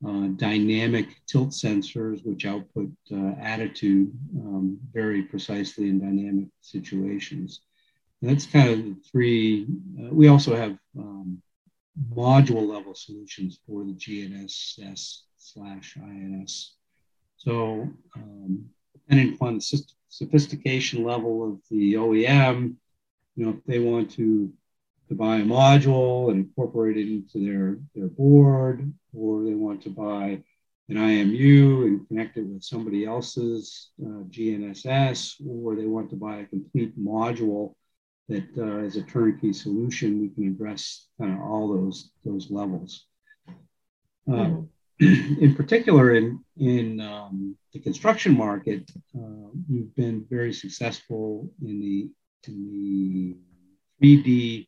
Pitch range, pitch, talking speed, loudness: 100-135 Hz, 110 Hz, 130 wpm, -23 LUFS